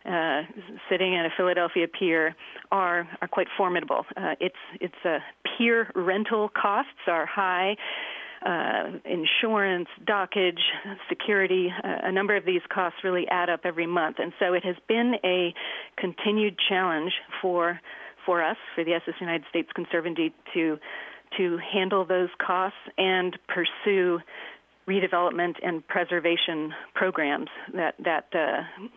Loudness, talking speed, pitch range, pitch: -26 LUFS, 135 wpm, 175-195 Hz, 180 Hz